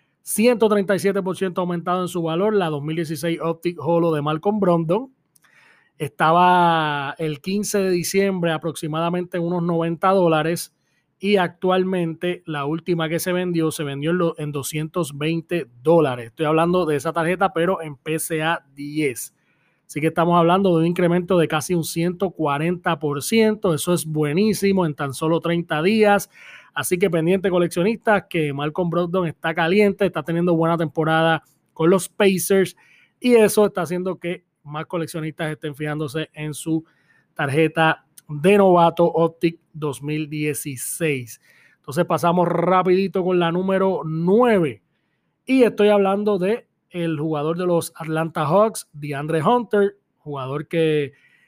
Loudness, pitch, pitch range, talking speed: -20 LUFS, 170 Hz, 155-185 Hz, 135 wpm